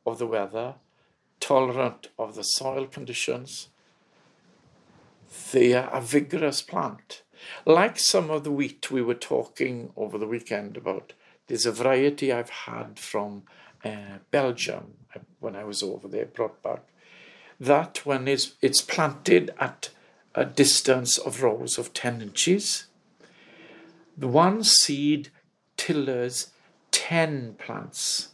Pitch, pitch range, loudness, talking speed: 135 Hz, 120-150 Hz, -25 LUFS, 125 wpm